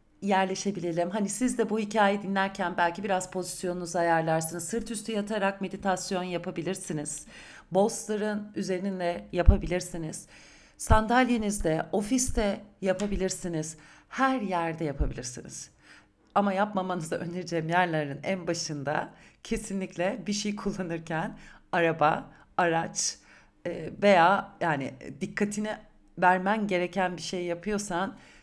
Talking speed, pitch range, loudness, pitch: 95 wpm, 170-205 Hz, -29 LUFS, 185 Hz